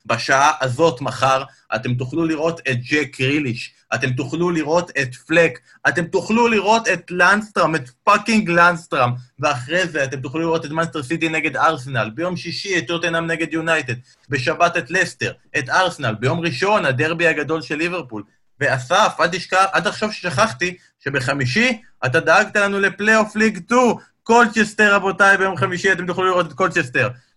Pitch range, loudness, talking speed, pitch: 140-185 Hz, -18 LUFS, 150 wpm, 165 Hz